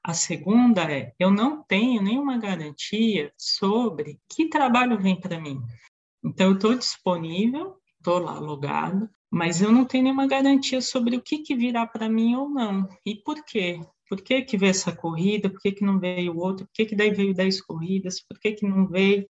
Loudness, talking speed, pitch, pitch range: -24 LUFS, 200 wpm, 200 Hz, 185-240 Hz